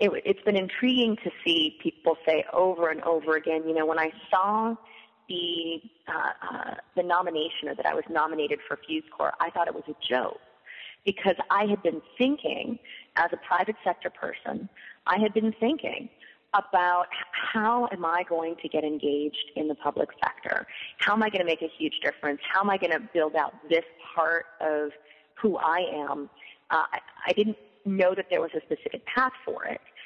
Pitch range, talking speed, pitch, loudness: 160-220 Hz, 195 wpm, 180 Hz, -28 LUFS